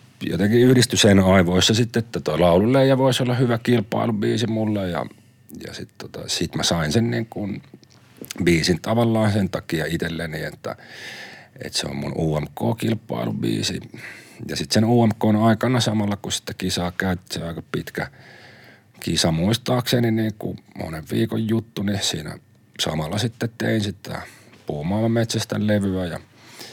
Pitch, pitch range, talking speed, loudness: 110 Hz, 95-115 Hz, 135 wpm, -21 LUFS